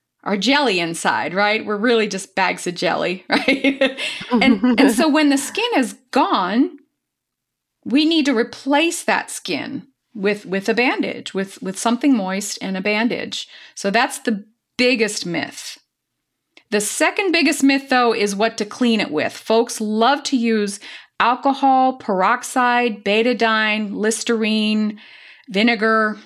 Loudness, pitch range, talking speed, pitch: -18 LUFS, 210-270 Hz, 140 wpm, 235 Hz